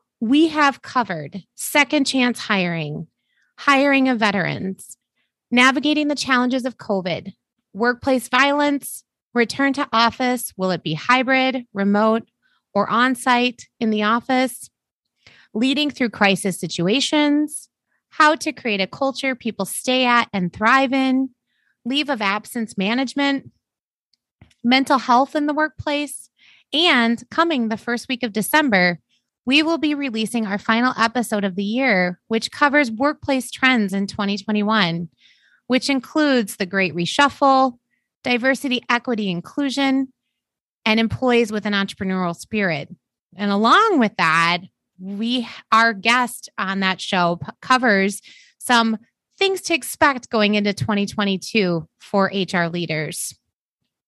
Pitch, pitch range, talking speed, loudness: 240 Hz, 200-270 Hz, 125 wpm, -19 LUFS